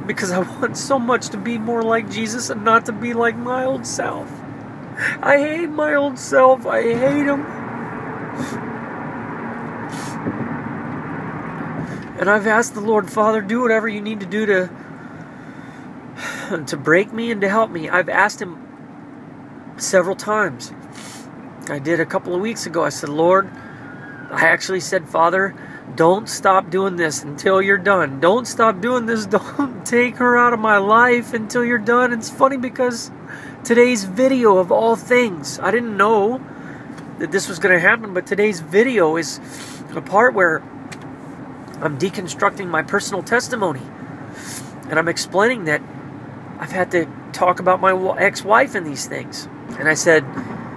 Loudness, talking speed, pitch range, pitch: -18 LUFS, 155 wpm, 185-240 Hz, 210 Hz